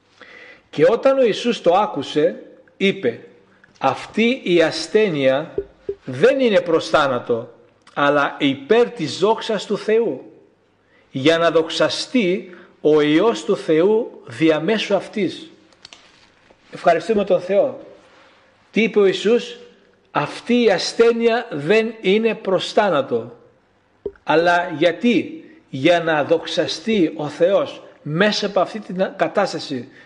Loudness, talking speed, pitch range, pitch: -18 LUFS, 110 wpm, 165-235 Hz, 200 Hz